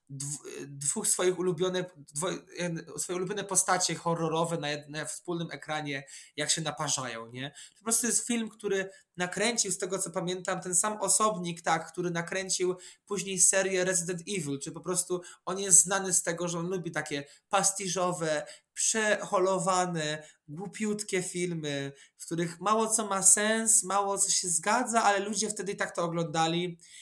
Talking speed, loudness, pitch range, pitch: 145 wpm, -28 LUFS, 165-195 Hz, 180 Hz